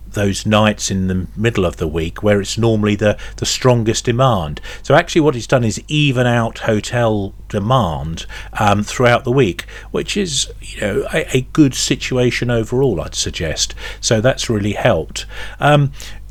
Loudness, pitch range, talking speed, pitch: -16 LUFS, 100-125 Hz, 165 wpm, 110 Hz